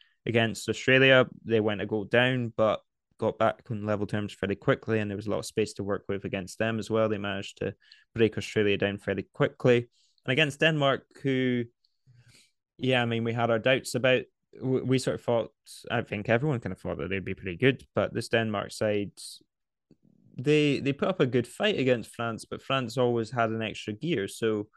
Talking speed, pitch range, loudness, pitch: 205 wpm, 105-130 Hz, -28 LUFS, 115 Hz